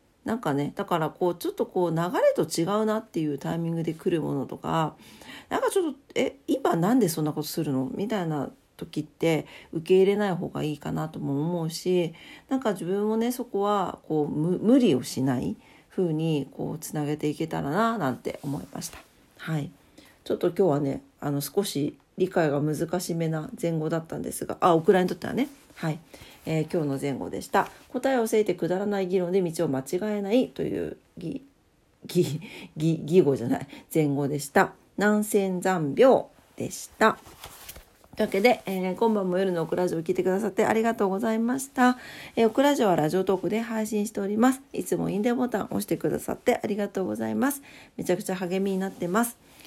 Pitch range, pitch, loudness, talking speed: 160-215 Hz, 185 Hz, -26 LUFS, 400 characters per minute